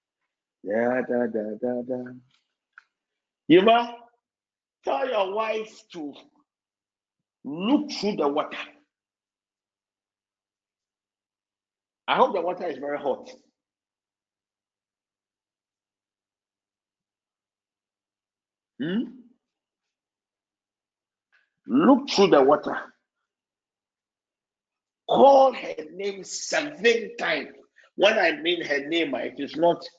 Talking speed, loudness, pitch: 80 wpm, -23 LUFS, 115 Hz